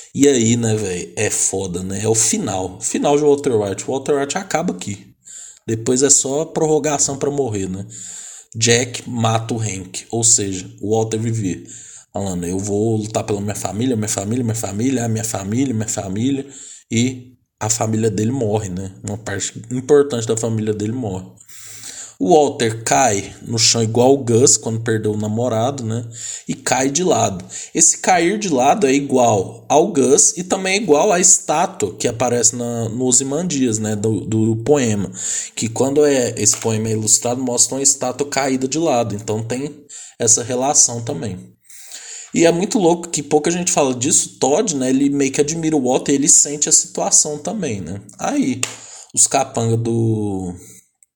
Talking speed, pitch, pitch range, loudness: 180 wpm, 120 Hz, 110-140 Hz, -17 LUFS